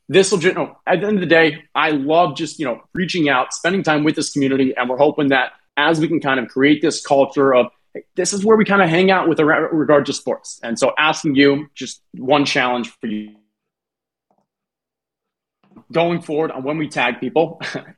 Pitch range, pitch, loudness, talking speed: 140-165 Hz, 150 Hz, -17 LUFS, 205 wpm